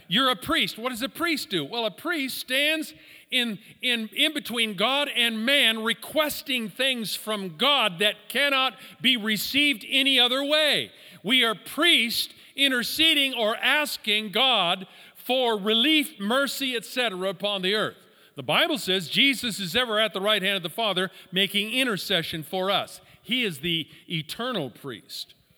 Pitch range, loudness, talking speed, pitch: 205-270 Hz, -23 LUFS, 155 wpm, 230 Hz